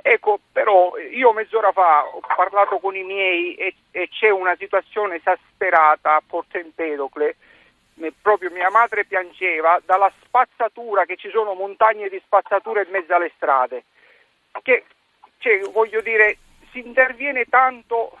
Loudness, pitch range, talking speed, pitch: -19 LUFS, 180-245 Hz, 135 wpm, 200 Hz